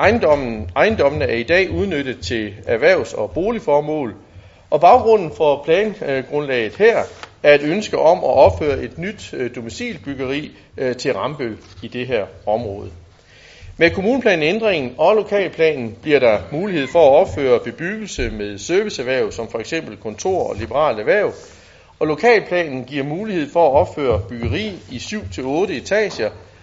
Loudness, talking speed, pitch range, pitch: -18 LUFS, 135 wpm, 110-180 Hz, 145 Hz